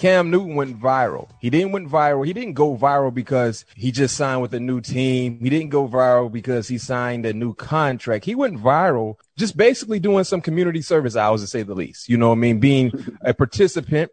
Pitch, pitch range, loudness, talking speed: 130 Hz, 120-165 Hz, -20 LUFS, 220 wpm